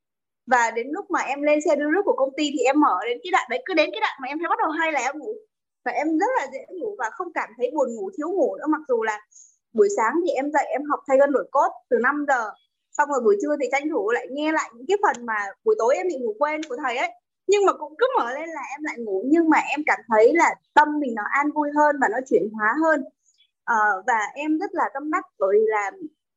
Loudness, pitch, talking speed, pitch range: -22 LUFS, 295 Hz, 280 wpm, 255-365 Hz